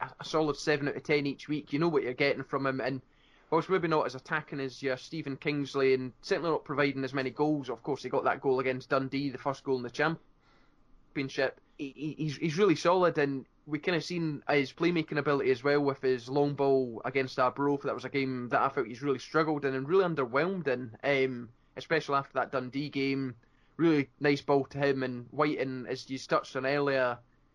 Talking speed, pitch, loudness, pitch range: 220 wpm, 140 Hz, -31 LUFS, 130-150 Hz